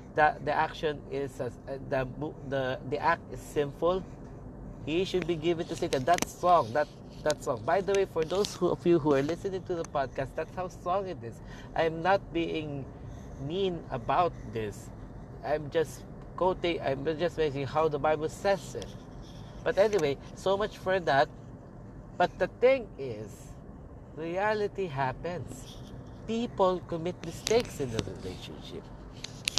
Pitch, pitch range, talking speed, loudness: 155 Hz, 135-180 Hz, 155 wpm, -30 LUFS